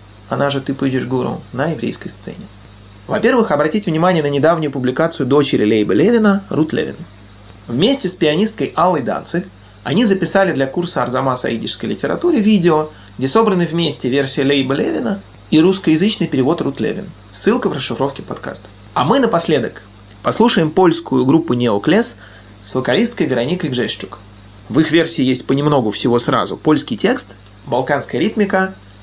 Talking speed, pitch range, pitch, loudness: 145 wpm, 110-175 Hz, 145 Hz, -16 LUFS